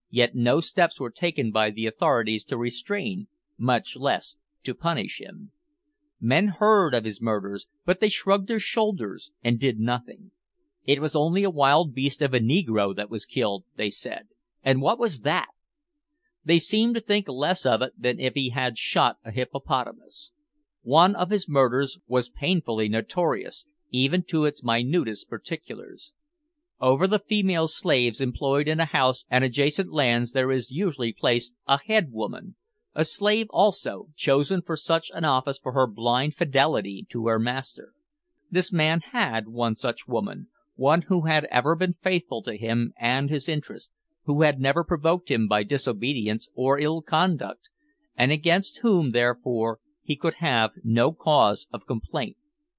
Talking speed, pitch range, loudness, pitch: 165 wpm, 125-200 Hz, -25 LUFS, 150 Hz